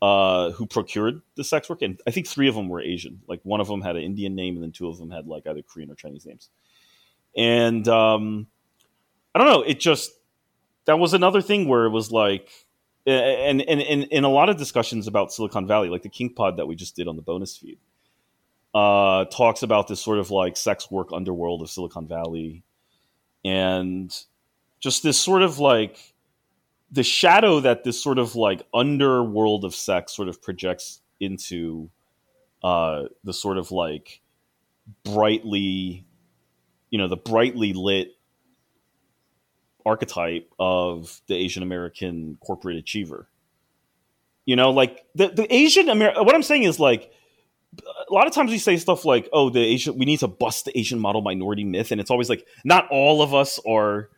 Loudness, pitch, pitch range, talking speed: -21 LUFS, 105 Hz, 90-130 Hz, 185 wpm